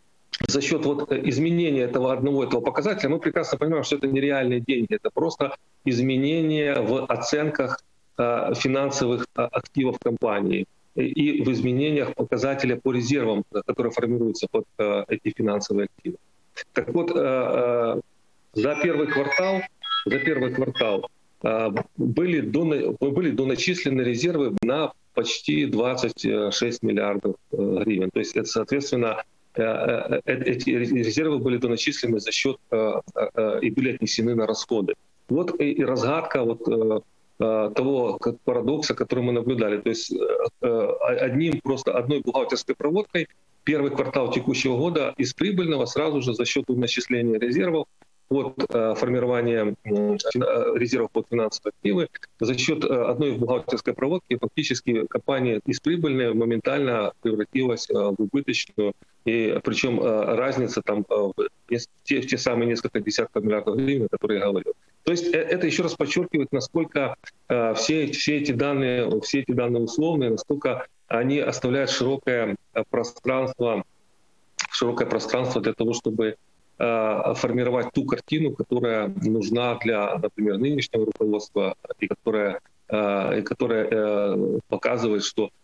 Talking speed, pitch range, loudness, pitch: 125 wpm, 115-145 Hz, -24 LUFS, 125 Hz